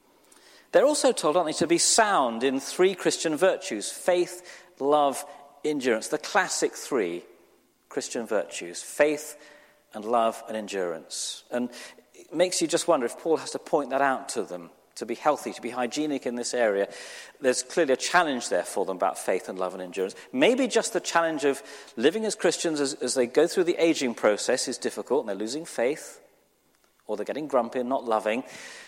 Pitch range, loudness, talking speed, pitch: 120-170 Hz, -26 LUFS, 190 wpm, 140 Hz